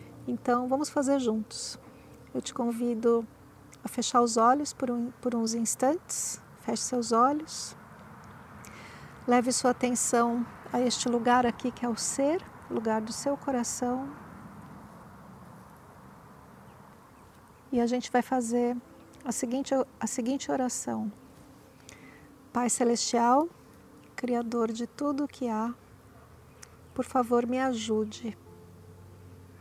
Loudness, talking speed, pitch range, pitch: -29 LUFS, 115 wpm, 235-255 Hz, 245 Hz